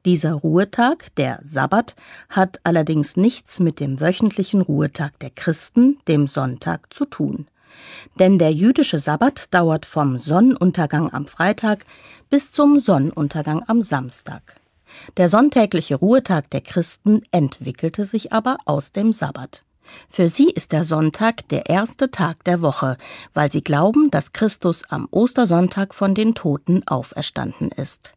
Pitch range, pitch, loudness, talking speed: 150-220 Hz, 175 Hz, -19 LUFS, 135 wpm